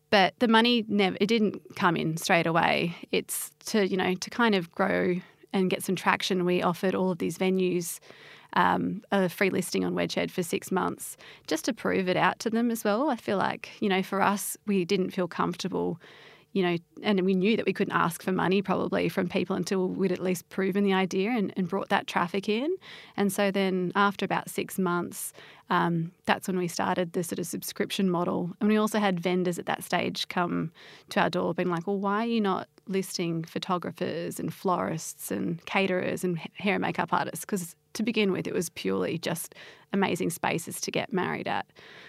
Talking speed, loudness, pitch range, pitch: 205 wpm, -28 LUFS, 180-200 Hz, 190 Hz